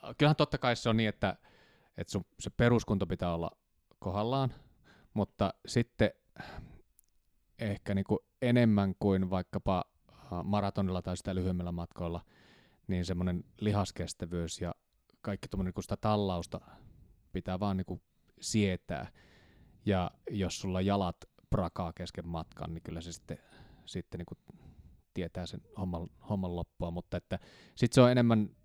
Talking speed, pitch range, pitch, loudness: 130 wpm, 85-105 Hz, 95 Hz, -34 LUFS